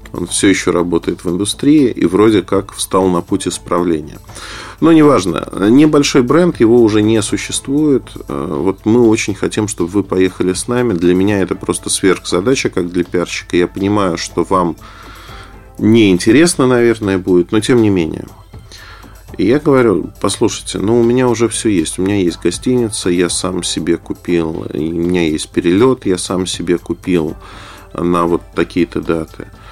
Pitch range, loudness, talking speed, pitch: 90-115 Hz, -13 LUFS, 160 wpm, 95 Hz